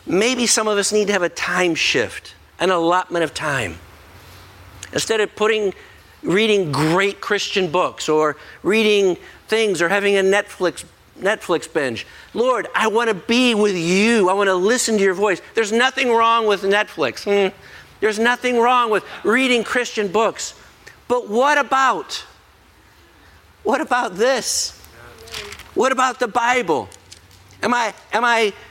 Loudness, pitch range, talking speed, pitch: -18 LUFS, 175-230 Hz, 145 wpm, 205 Hz